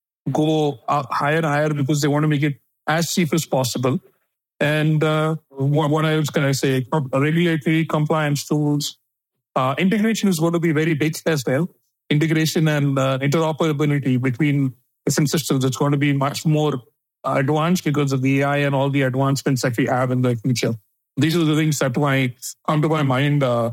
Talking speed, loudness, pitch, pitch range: 190 wpm, -20 LUFS, 150 Hz, 135-155 Hz